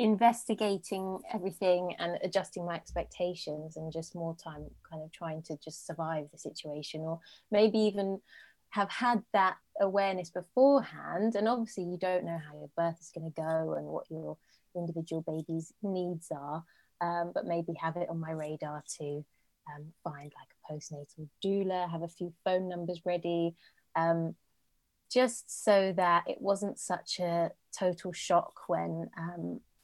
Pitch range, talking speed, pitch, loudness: 160-190 Hz, 155 wpm, 170 Hz, -33 LUFS